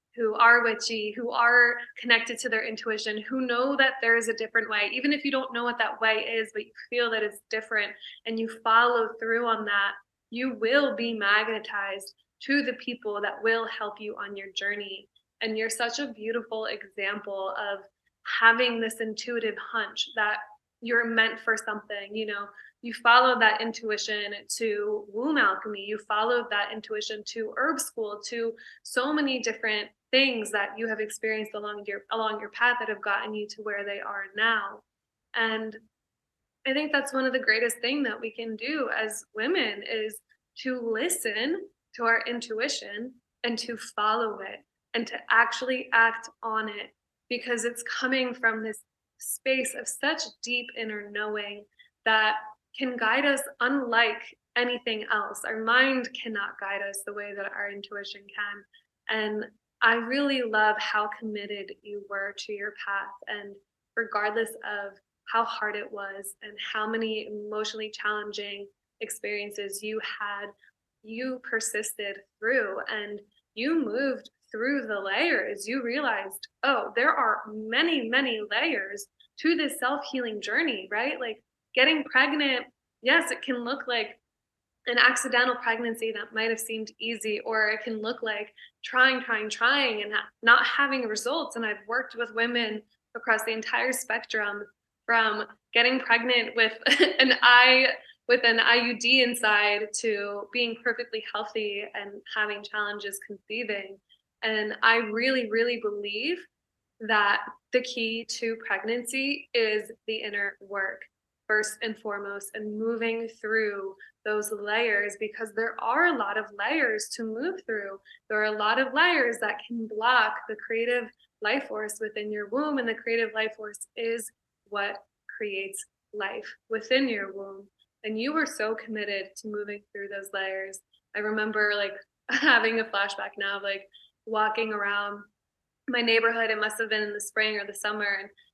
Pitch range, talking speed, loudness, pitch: 210-240 Hz, 160 wpm, -27 LUFS, 225 Hz